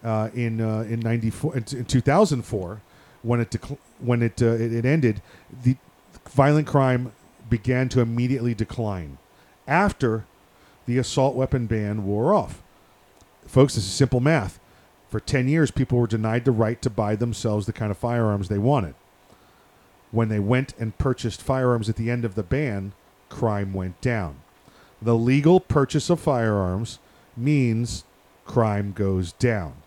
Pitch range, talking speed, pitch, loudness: 105-130 Hz, 155 wpm, 115 Hz, -23 LUFS